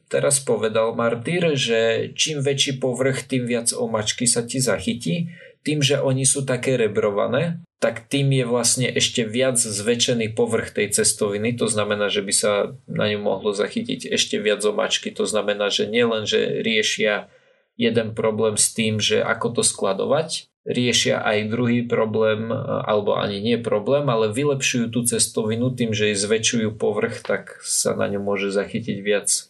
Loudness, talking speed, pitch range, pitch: -21 LUFS, 160 wpm, 110-140 Hz, 120 Hz